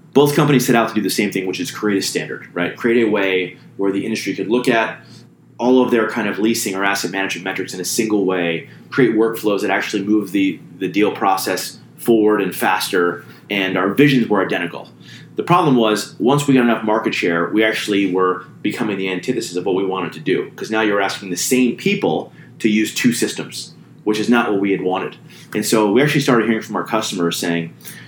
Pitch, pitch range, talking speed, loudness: 105 Hz, 95-120 Hz, 220 wpm, -18 LUFS